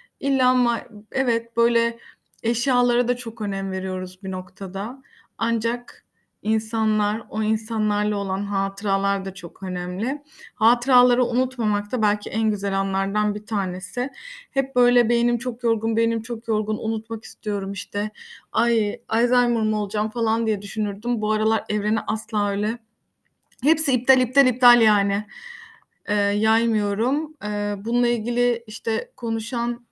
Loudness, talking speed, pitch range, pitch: -23 LUFS, 130 wpm, 205-240 Hz, 225 Hz